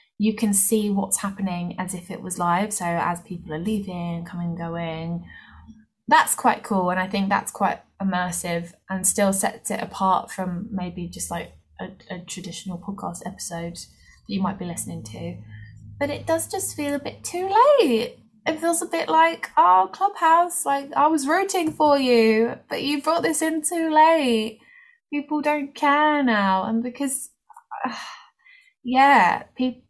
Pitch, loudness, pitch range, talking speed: 215 Hz, -22 LUFS, 180-300 Hz, 170 wpm